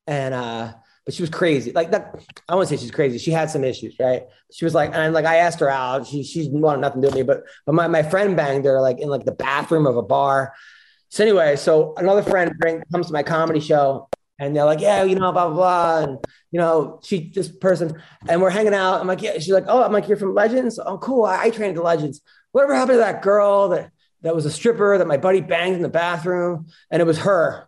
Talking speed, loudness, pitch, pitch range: 260 wpm, -19 LUFS, 165 Hz, 145-190 Hz